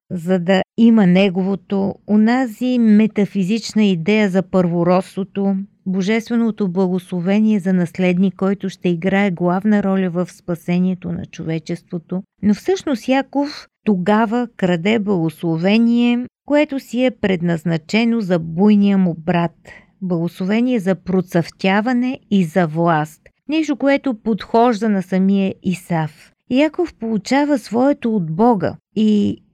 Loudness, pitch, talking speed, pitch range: -17 LUFS, 195 Hz, 110 wpm, 185-225 Hz